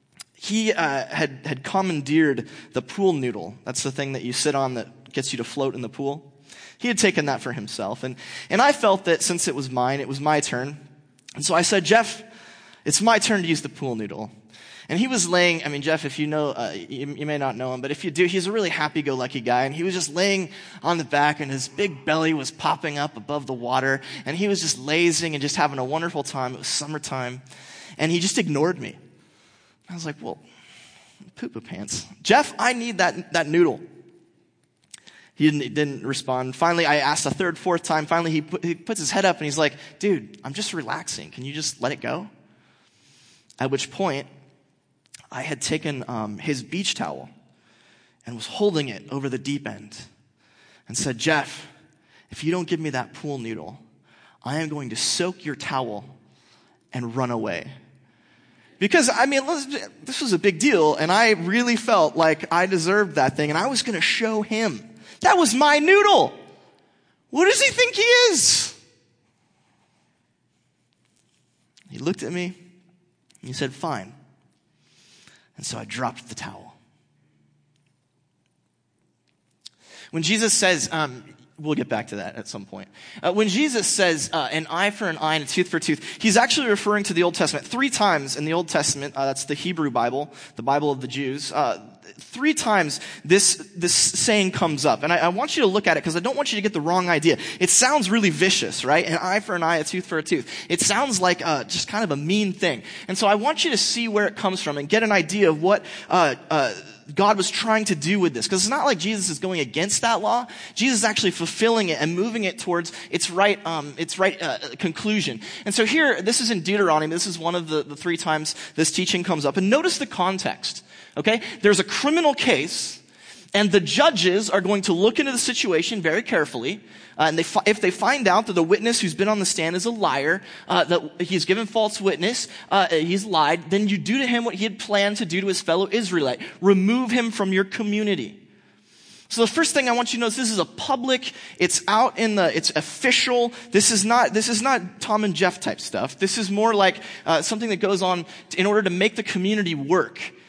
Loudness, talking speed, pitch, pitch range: -22 LUFS, 215 wpm, 175 Hz, 150-210 Hz